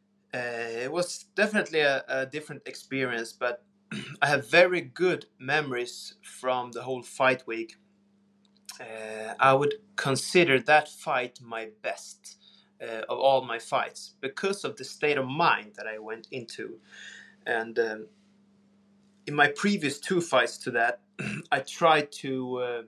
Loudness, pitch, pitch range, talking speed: -27 LUFS, 145 Hz, 125-200 Hz, 145 wpm